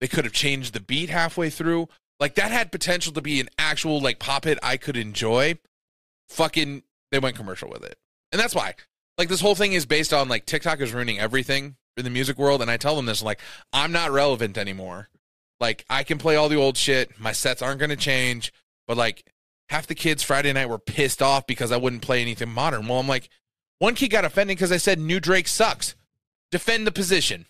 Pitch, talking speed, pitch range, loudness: 140 Hz, 225 wpm, 125-165 Hz, -23 LUFS